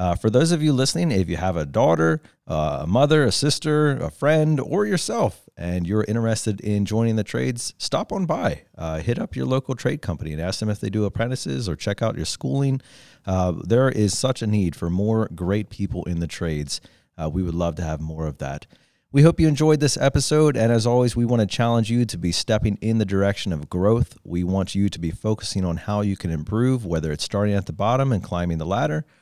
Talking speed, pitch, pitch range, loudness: 235 wpm, 105 Hz, 90-130 Hz, -22 LUFS